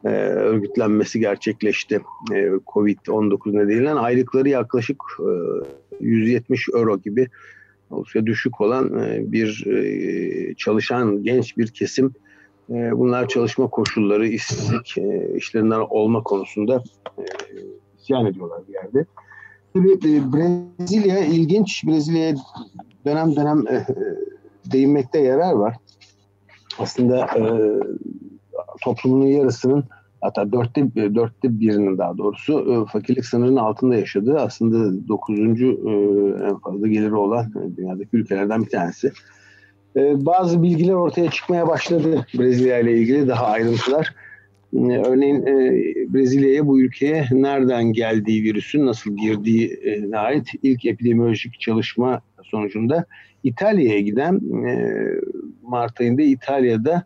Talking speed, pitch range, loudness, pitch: 105 wpm, 110-150 Hz, -19 LUFS, 125 Hz